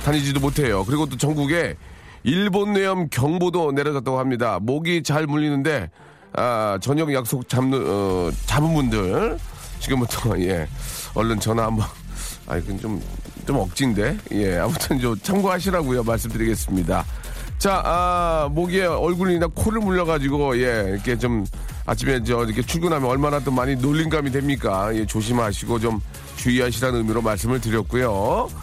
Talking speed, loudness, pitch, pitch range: 325 characters per minute, -22 LUFS, 130 Hz, 110-150 Hz